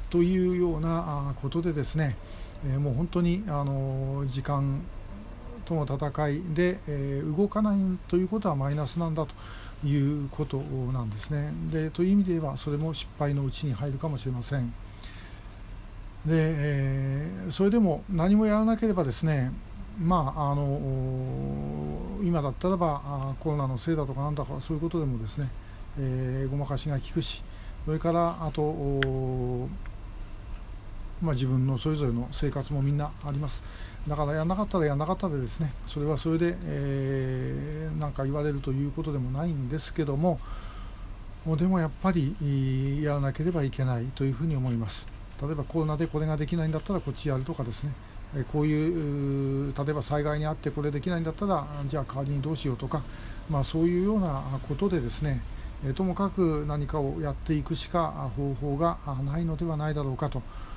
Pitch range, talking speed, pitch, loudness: 130-160 Hz, 350 characters per minute, 145 Hz, -29 LUFS